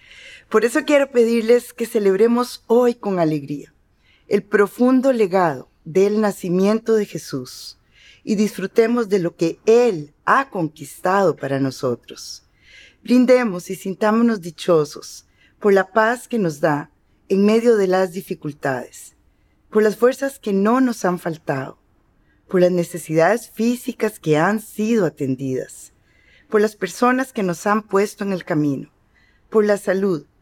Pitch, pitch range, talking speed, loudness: 200 Hz, 165-230 Hz, 140 wpm, -19 LUFS